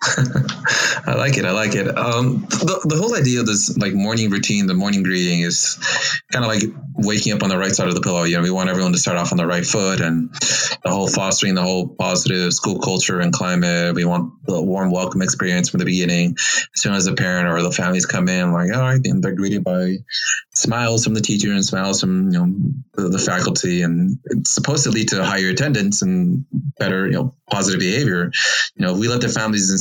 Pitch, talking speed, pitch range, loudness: 95 Hz, 230 wpm, 90-125 Hz, -18 LUFS